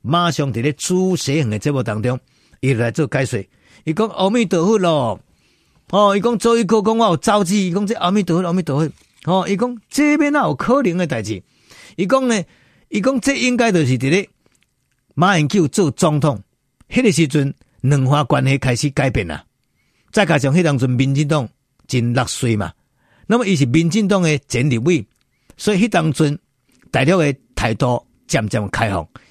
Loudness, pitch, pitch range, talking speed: -17 LUFS, 155 Hz, 130-195 Hz, 260 characters per minute